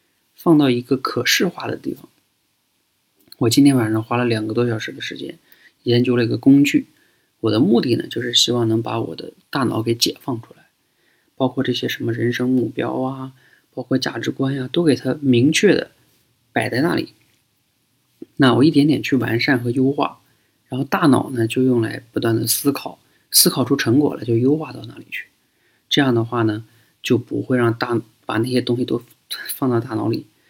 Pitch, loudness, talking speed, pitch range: 125 Hz, -19 LUFS, 270 characters per minute, 115-135 Hz